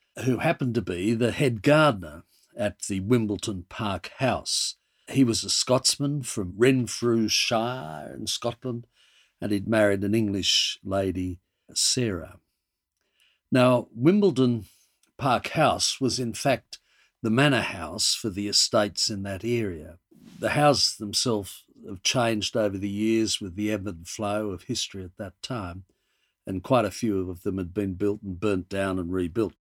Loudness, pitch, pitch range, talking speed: -25 LUFS, 105 Hz, 95-120 Hz, 150 wpm